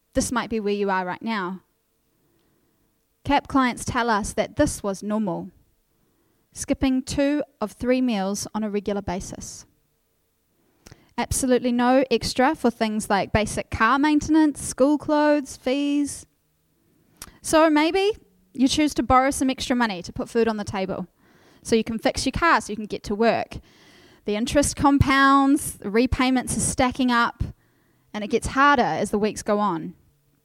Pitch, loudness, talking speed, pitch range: 245 Hz, -22 LUFS, 160 wpm, 210-275 Hz